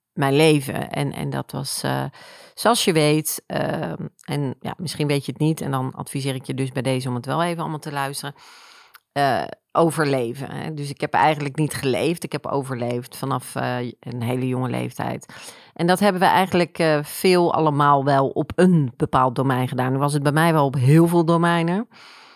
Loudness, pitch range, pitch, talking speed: -21 LUFS, 130-165 Hz, 145 Hz, 200 wpm